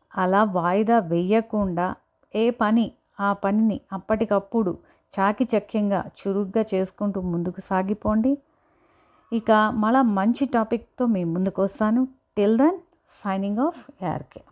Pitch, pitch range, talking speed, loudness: 215 Hz, 195-230 Hz, 105 wpm, -23 LUFS